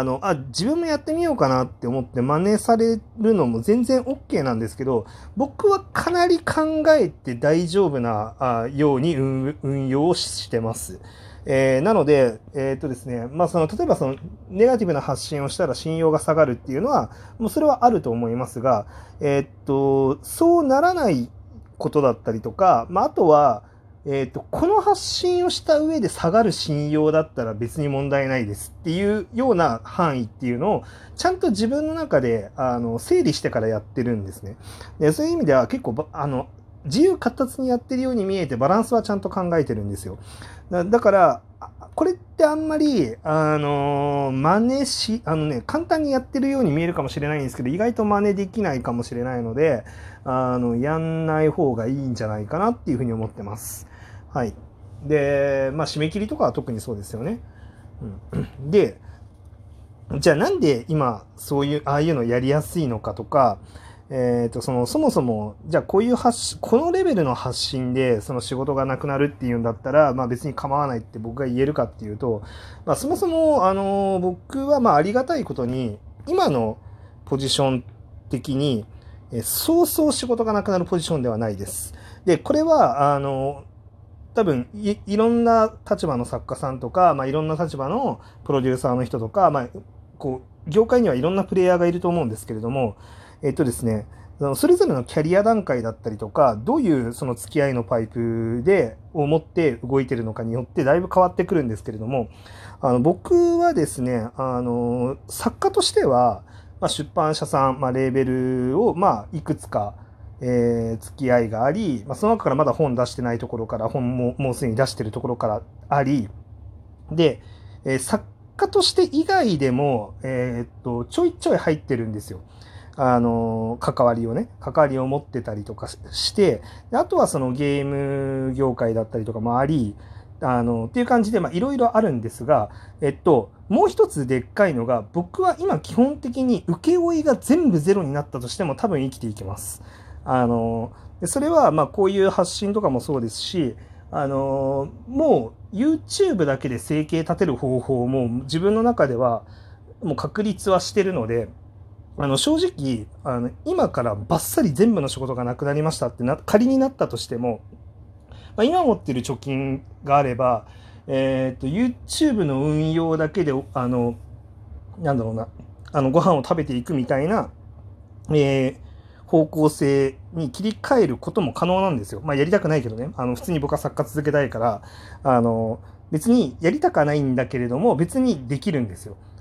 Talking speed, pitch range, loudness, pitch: 360 characters per minute, 115-180 Hz, -22 LUFS, 135 Hz